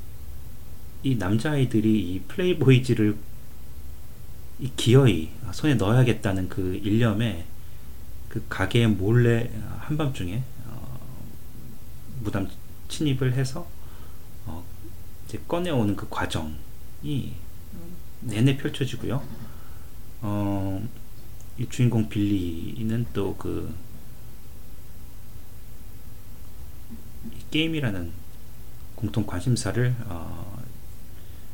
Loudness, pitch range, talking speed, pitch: -26 LUFS, 95-120 Hz, 170 characters per minute, 110 Hz